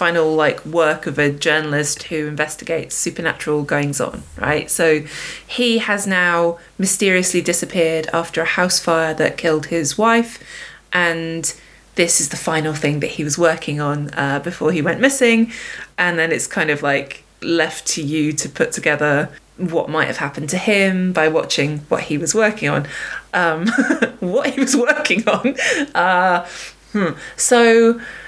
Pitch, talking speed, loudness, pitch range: 165 Hz, 160 wpm, -17 LUFS, 155-195 Hz